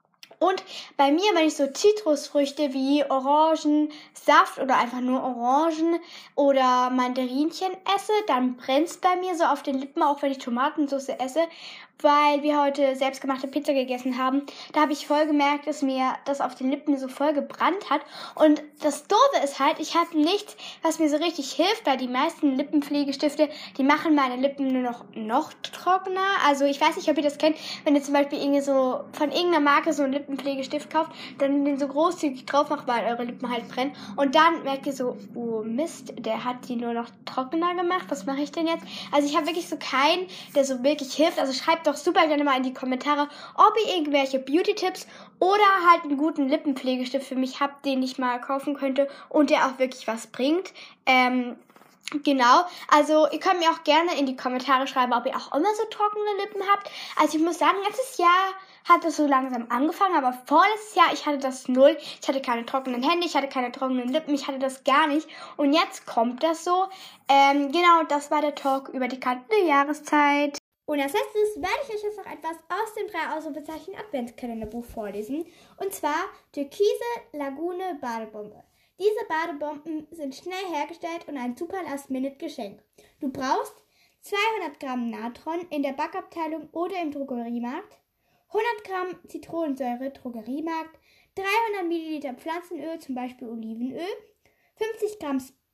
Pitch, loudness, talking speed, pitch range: 290 Hz, -24 LUFS, 180 wpm, 265-330 Hz